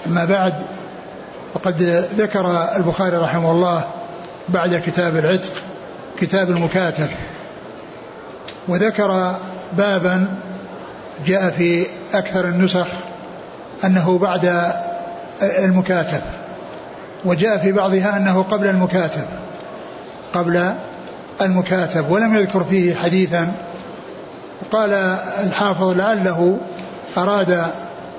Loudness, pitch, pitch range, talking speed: -18 LUFS, 185 Hz, 175-190 Hz, 80 wpm